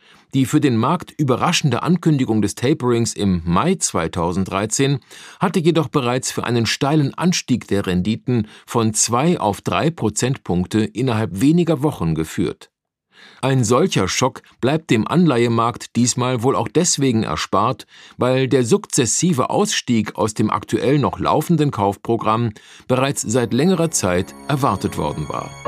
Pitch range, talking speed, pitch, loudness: 110-155 Hz, 135 wpm, 125 Hz, -18 LUFS